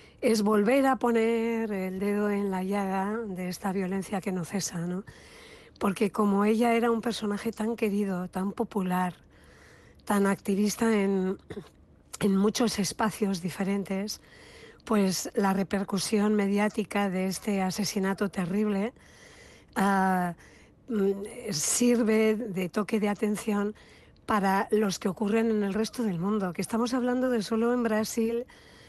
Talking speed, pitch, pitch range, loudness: 130 wpm, 205 Hz, 195-225 Hz, -28 LUFS